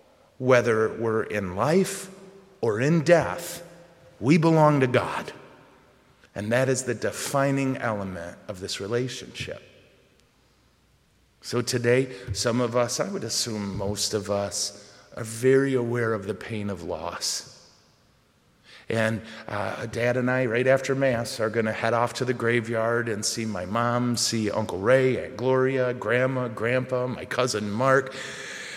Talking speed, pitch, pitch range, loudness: 145 wpm, 120 Hz, 110-130 Hz, -25 LUFS